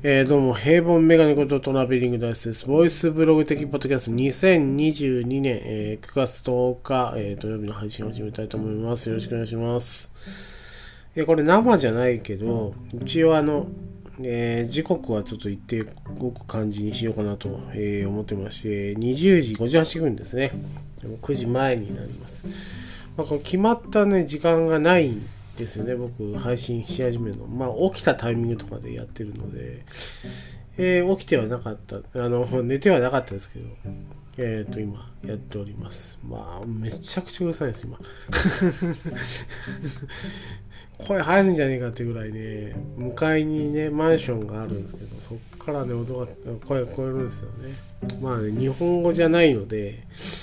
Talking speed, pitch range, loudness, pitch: 340 characters per minute, 110-150 Hz, -23 LUFS, 125 Hz